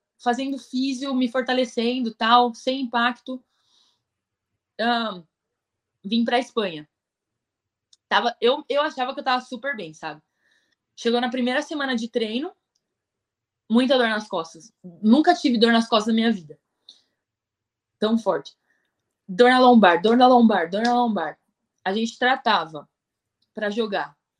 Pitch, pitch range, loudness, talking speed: 230 Hz, 185-250 Hz, -21 LUFS, 140 wpm